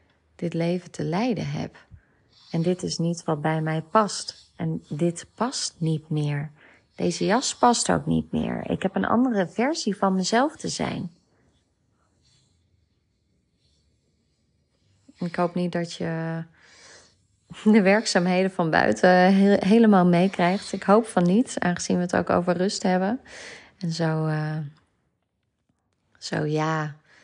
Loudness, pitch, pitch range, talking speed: -23 LUFS, 175 Hz, 155-195 Hz, 135 wpm